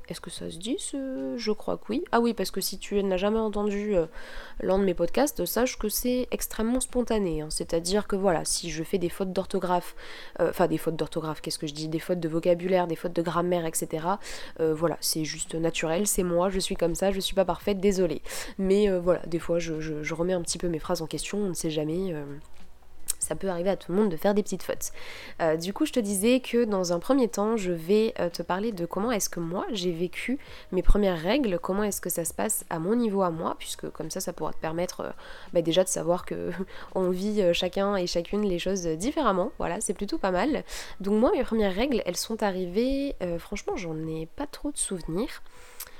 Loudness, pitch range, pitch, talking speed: -28 LUFS, 170-215 Hz, 190 Hz, 240 wpm